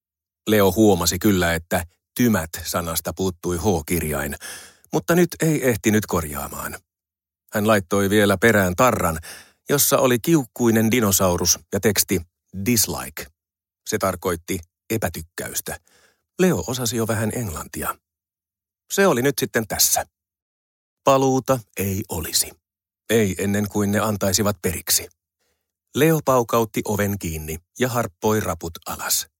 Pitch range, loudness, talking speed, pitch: 85-115 Hz, -21 LUFS, 110 wpm, 100 Hz